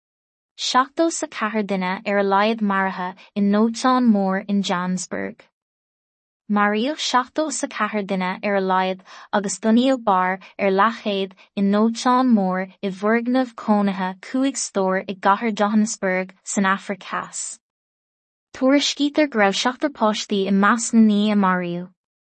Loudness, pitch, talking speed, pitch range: -20 LUFS, 205 Hz, 90 wpm, 195-230 Hz